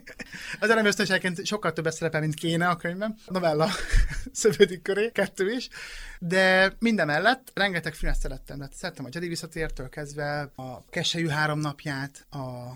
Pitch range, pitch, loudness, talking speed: 150-200 Hz, 170 Hz, -26 LUFS, 155 wpm